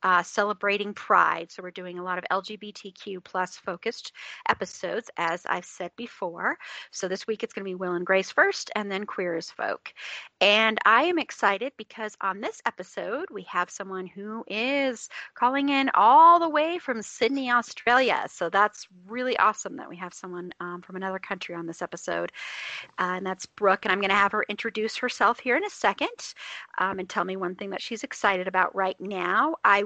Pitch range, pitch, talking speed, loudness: 185-235 Hz, 200 Hz, 195 wpm, -26 LUFS